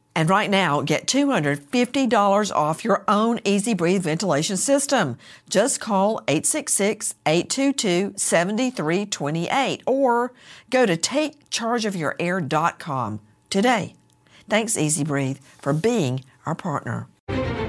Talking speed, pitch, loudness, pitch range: 100 wpm, 195 Hz, -22 LUFS, 150-230 Hz